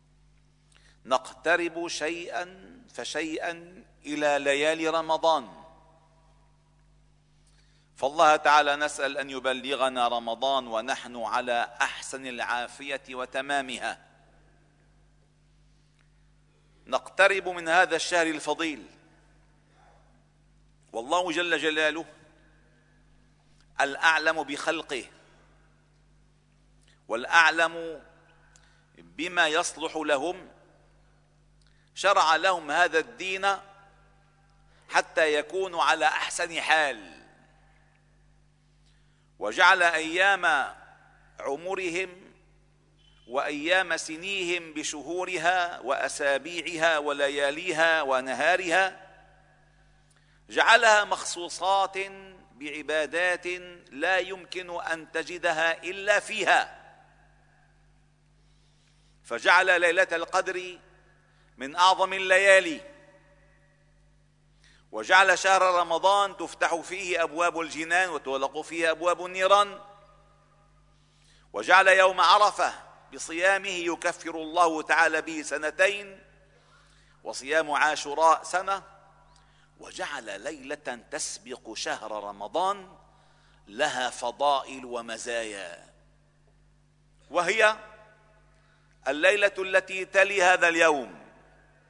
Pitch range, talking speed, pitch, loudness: 150-180 Hz, 65 wpm, 160 Hz, -25 LUFS